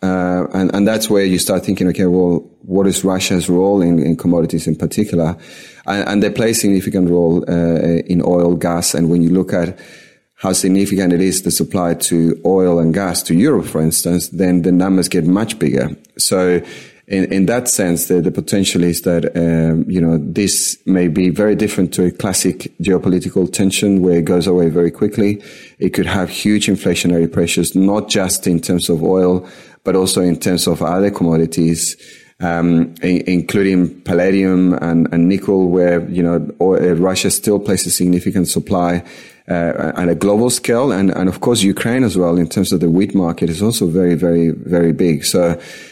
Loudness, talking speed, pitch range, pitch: -15 LUFS, 190 wpm, 85-95 Hz, 90 Hz